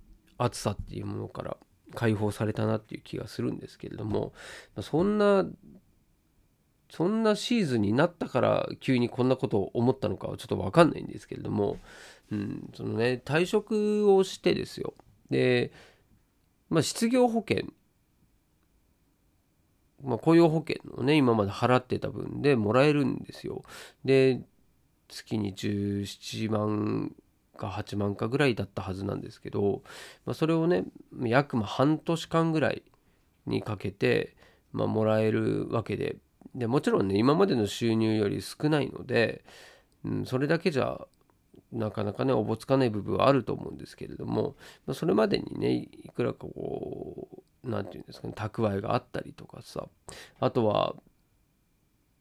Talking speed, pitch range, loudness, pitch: 285 characters per minute, 105-150 Hz, -28 LUFS, 120 Hz